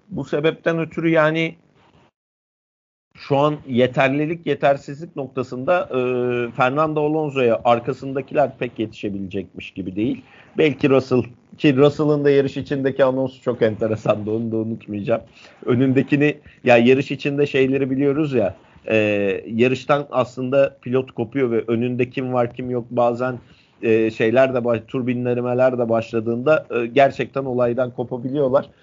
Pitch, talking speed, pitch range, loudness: 130 Hz, 125 wpm, 120-145 Hz, -20 LUFS